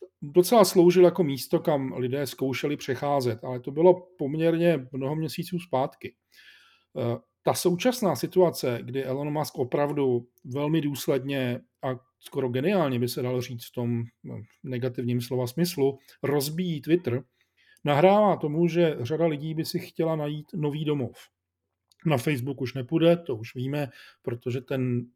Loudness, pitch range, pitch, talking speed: -26 LUFS, 125-165 Hz, 140 Hz, 140 wpm